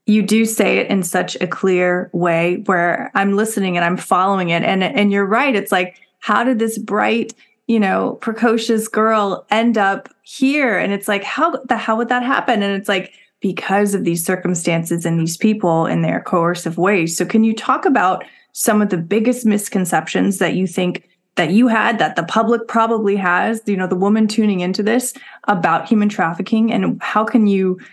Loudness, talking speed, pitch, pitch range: -17 LUFS, 195 wpm, 205 Hz, 180-225 Hz